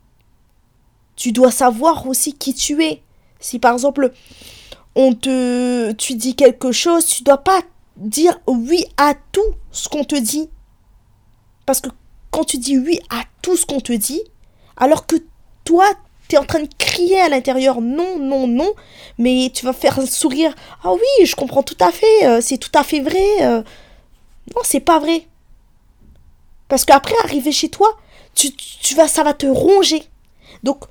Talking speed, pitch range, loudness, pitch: 180 wpm, 255-325 Hz, -15 LUFS, 280 Hz